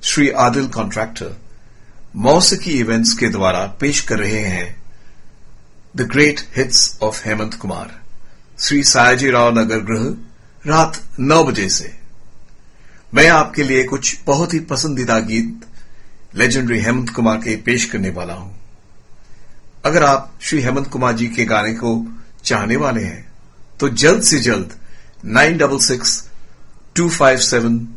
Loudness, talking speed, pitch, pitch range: -15 LUFS, 135 wpm, 120 Hz, 110-140 Hz